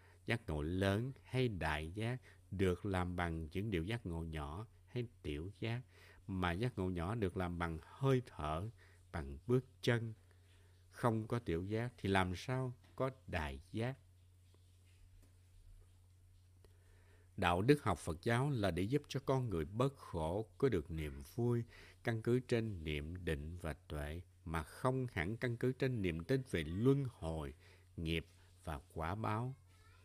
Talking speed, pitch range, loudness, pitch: 155 wpm, 85-115 Hz, -40 LUFS, 90 Hz